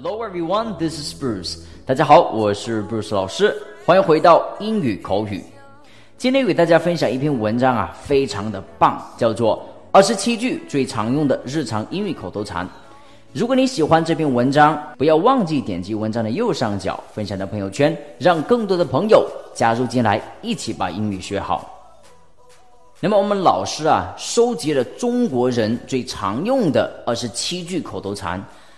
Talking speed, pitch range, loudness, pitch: 300 characters per minute, 105-175 Hz, -19 LUFS, 130 Hz